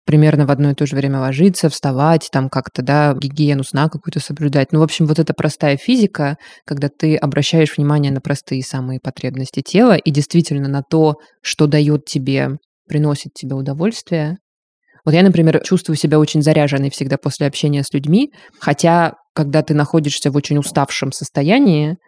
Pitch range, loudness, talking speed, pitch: 140-160 Hz, -16 LUFS, 170 wpm, 150 Hz